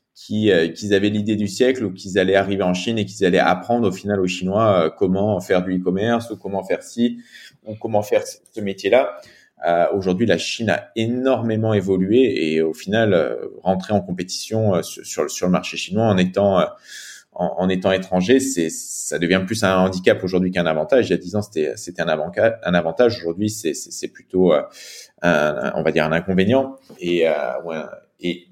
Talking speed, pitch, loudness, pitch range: 215 wpm, 95 Hz, -20 LUFS, 90-110 Hz